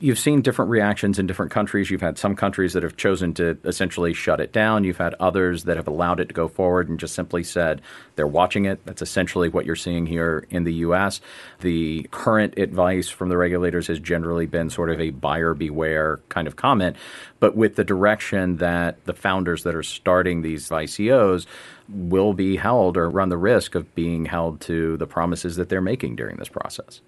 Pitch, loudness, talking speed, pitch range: 90 Hz, -22 LUFS, 205 wpm, 85-95 Hz